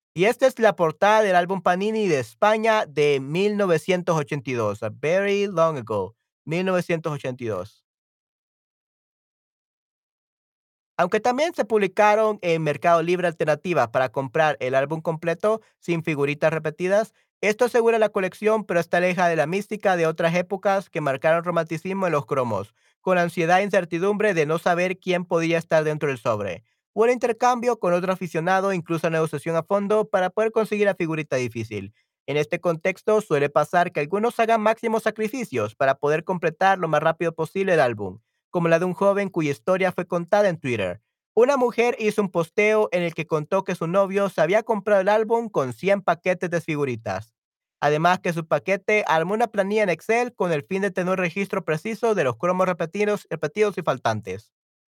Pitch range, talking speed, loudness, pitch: 160-205 Hz, 170 wpm, -22 LUFS, 180 Hz